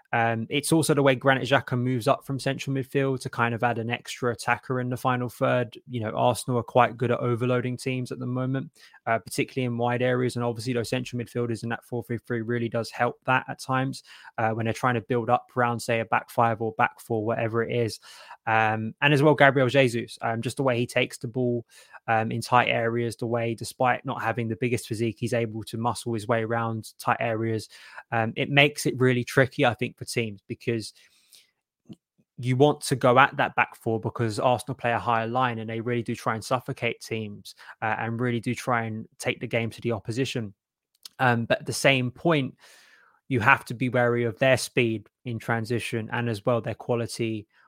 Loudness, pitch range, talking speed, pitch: -26 LUFS, 115-130 Hz, 220 wpm, 120 Hz